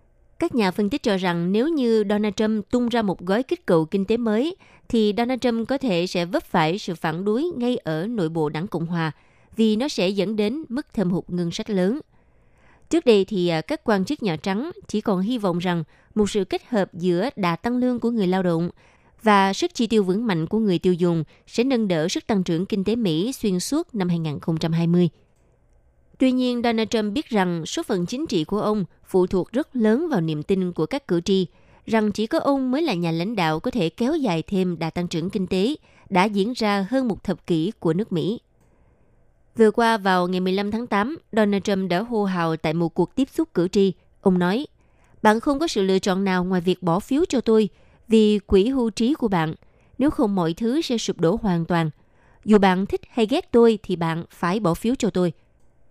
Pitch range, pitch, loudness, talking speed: 175-230 Hz, 200 Hz, -22 LUFS, 225 wpm